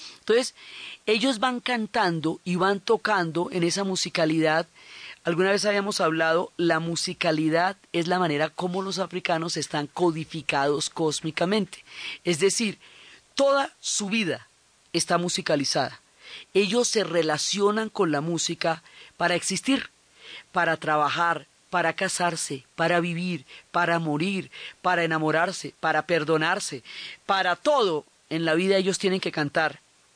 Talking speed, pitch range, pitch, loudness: 120 wpm, 160-195 Hz, 175 Hz, -25 LUFS